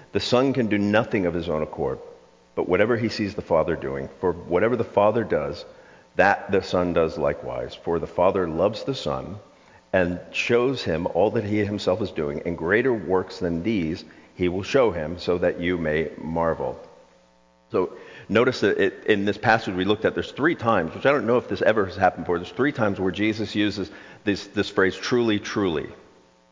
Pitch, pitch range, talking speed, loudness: 100 Hz, 85-110 Hz, 200 wpm, -24 LUFS